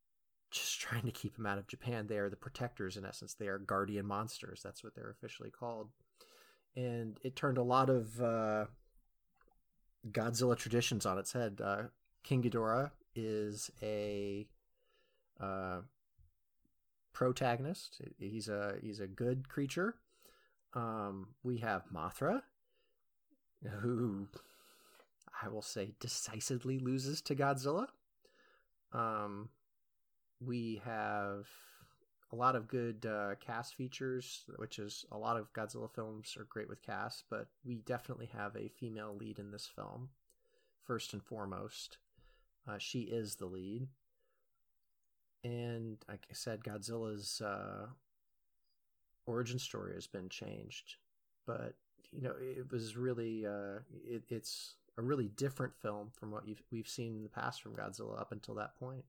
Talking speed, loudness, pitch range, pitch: 140 wpm, -41 LUFS, 105-125 Hz, 115 Hz